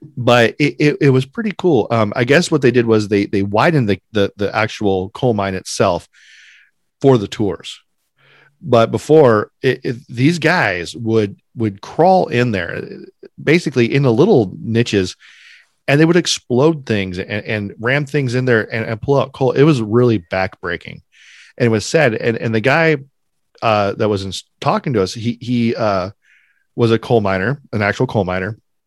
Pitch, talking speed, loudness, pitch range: 120 Hz, 185 wpm, -16 LUFS, 105-140 Hz